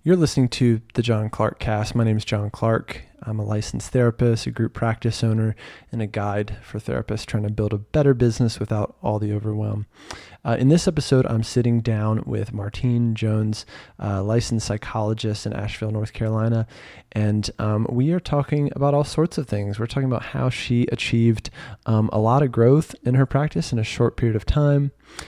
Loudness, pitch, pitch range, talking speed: -22 LUFS, 115 Hz, 105-125 Hz, 195 wpm